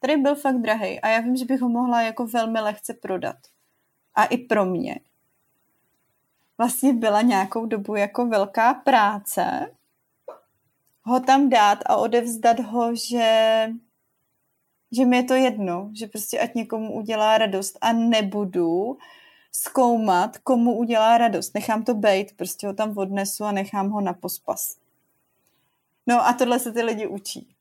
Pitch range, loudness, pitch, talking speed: 205-245 Hz, -22 LUFS, 225 Hz, 150 wpm